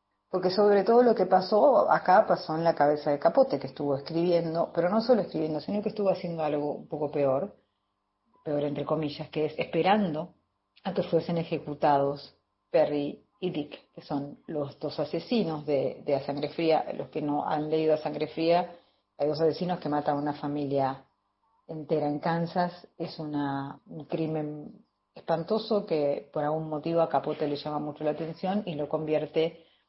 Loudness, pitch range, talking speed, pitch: -28 LUFS, 145-170 Hz, 180 wpm, 155 Hz